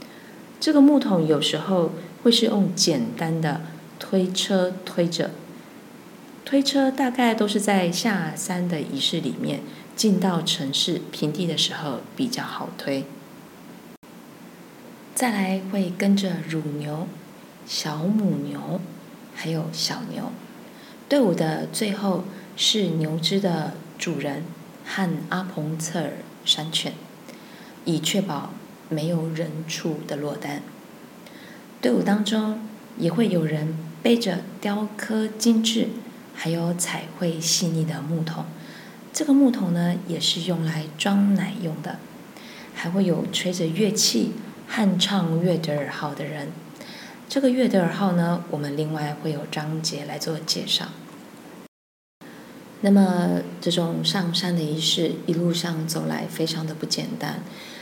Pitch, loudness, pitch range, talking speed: 180 Hz, -24 LUFS, 160-215 Hz, 185 characters per minute